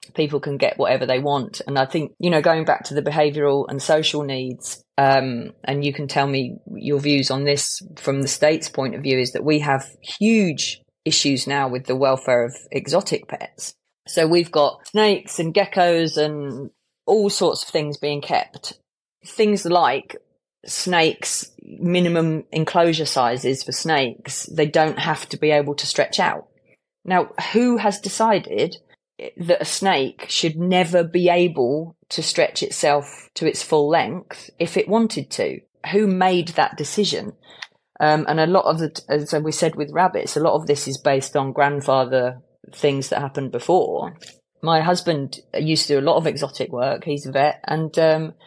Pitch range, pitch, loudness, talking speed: 140-175 Hz, 150 Hz, -20 LUFS, 175 wpm